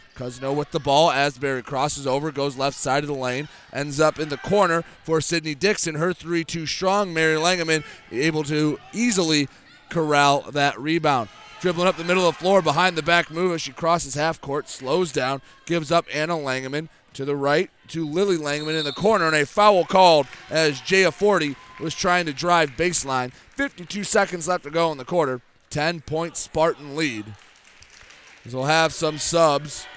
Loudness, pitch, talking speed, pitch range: -22 LUFS, 160 Hz, 190 wpm, 145-175 Hz